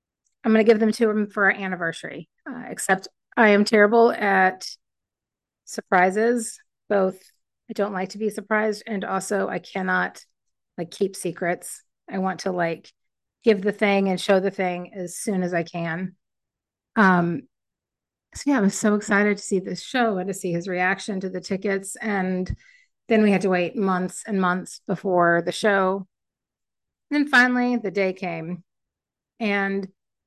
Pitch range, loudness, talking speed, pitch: 185-215 Hz, -22 LUFS, 170 wpm, 195 Hz